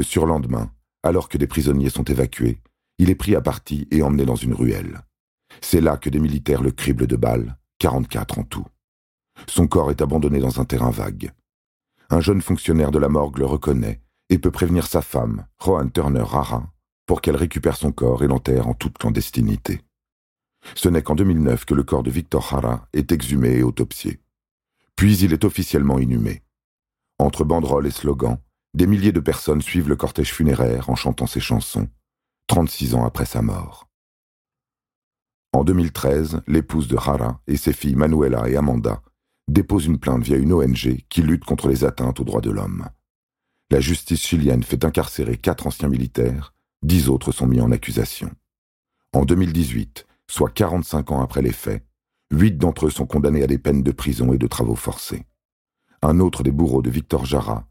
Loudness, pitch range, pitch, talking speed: -20 LUFS, 65-80 Hz, 70 Hz, 180 wpm